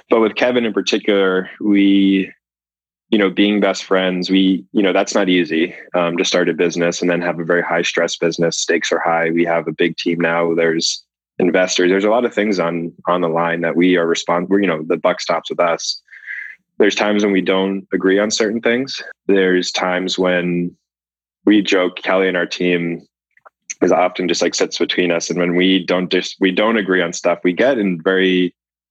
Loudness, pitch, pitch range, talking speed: -16 LUFS, 90 Hz, 85-95 Hz, 210 wpm